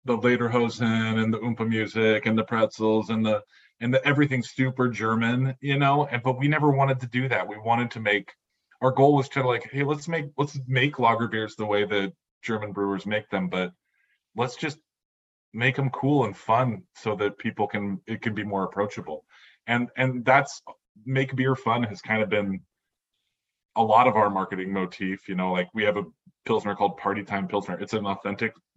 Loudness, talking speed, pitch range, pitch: -25 LUFS, 200 wpm, 100-130 Hz, 110 Hz